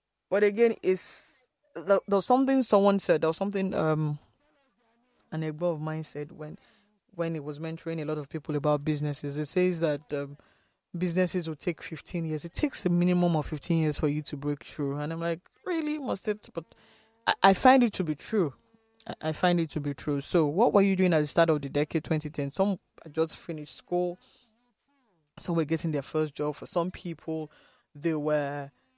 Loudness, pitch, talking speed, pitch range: -28 LUFS, 165 Hz, 200 wpm, 155-200 Hz